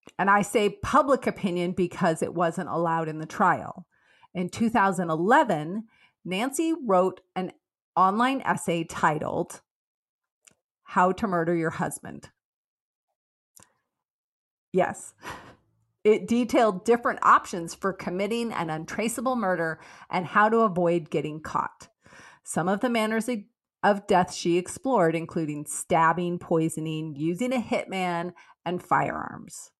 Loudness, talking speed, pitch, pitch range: -26 LUFS, 115 wpm, 185 Hz, 170-220 Hz